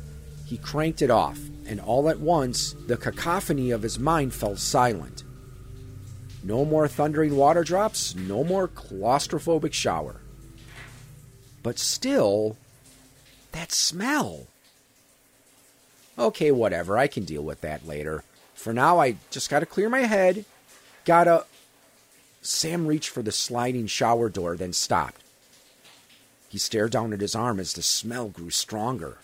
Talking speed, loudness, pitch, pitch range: 135 wpm, -25 LUFS, 130 Hz, 110-150 Hz